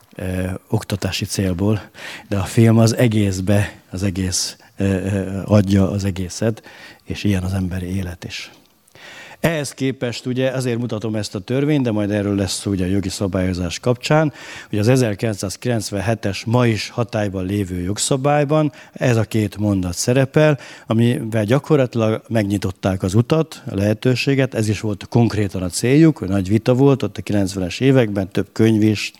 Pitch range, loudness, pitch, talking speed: 100-125 Hz, -19 LUFS, 105 Hz, 150 wpm